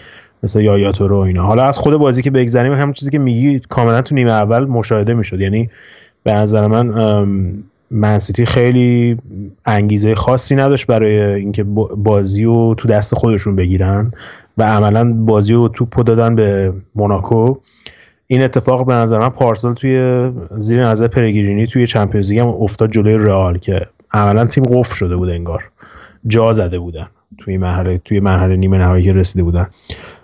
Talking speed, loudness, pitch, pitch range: 160 wpm, -13 LUFS, 110 Hz, 100-120 Hz